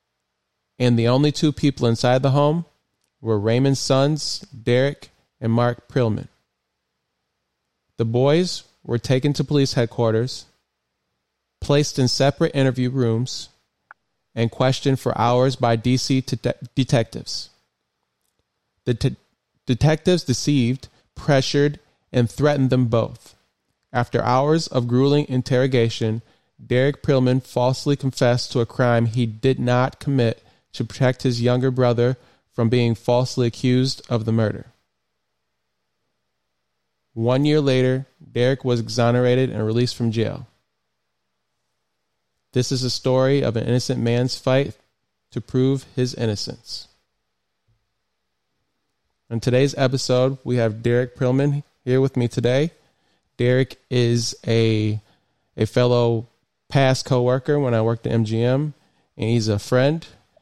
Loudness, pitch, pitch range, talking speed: -21 LUFS, 125 Hz, 115-135 Hz, 125 wpm